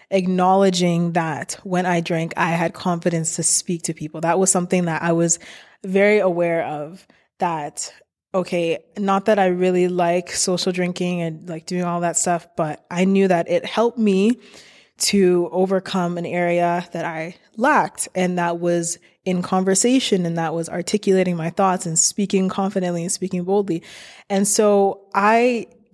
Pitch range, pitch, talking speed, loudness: 170-195 Hz, 180 Hz, 160 wpm, -20 LUFS